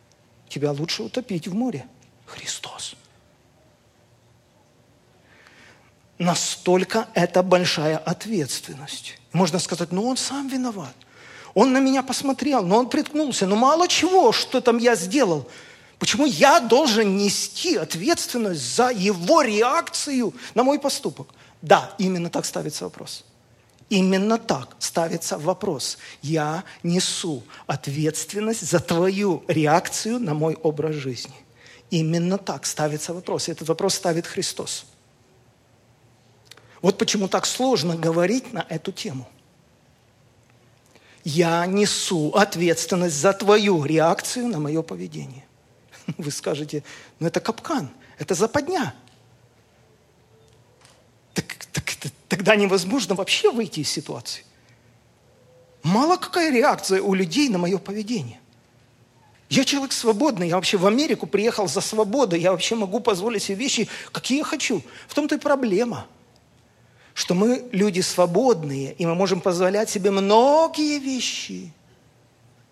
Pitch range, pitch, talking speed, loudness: 150-225 Hz, 185 Hz, 115 wpm, -22 LUFS